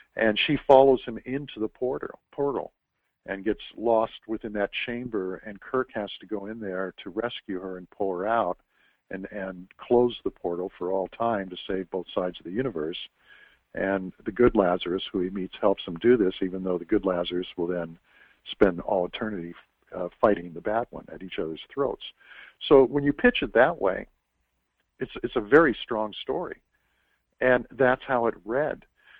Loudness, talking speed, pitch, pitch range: -26 LUFS, 185 wpm, 105 Hz, 95-120 Hz